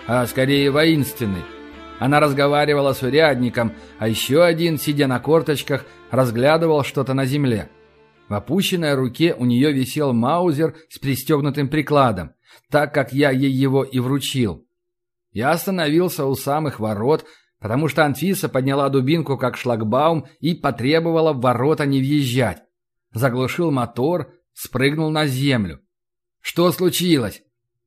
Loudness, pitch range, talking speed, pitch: -19 LUFS, 120-155 Hz, 125 wpm, 135 Hz